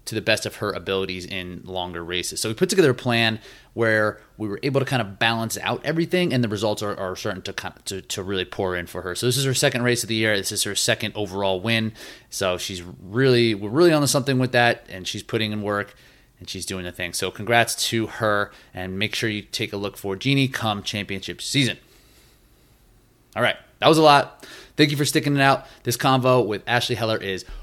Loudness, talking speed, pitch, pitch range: -22 LUFS, 235 wpm, 110 Hz, 95-125 Hz